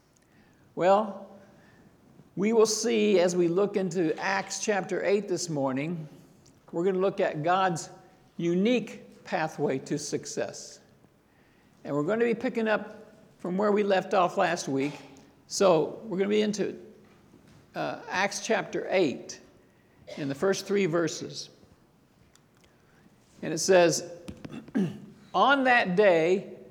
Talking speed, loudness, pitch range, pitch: 130 wpm, -27 LUFS, 170-205 Hz, 190 Hz